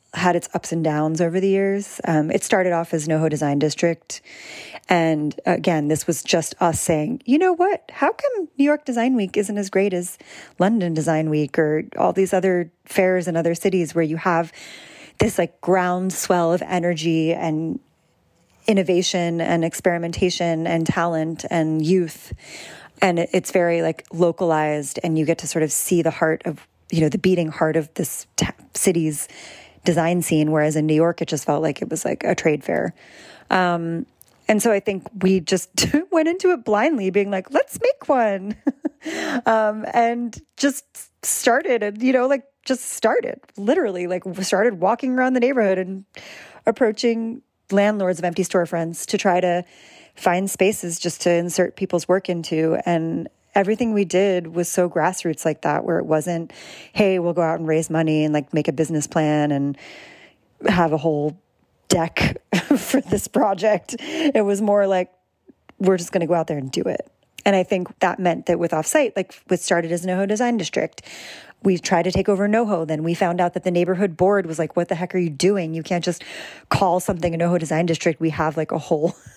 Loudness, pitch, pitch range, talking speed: -21 LUFS, 180 Hz, 165-200 Hz, 190 wpm